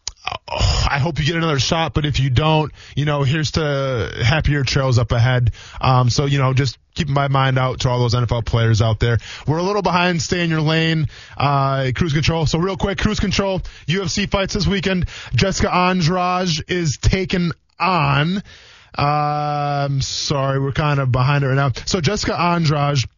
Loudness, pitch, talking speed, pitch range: -18 LUFS, 145 Hz, 185 wpm, 130-170 Hz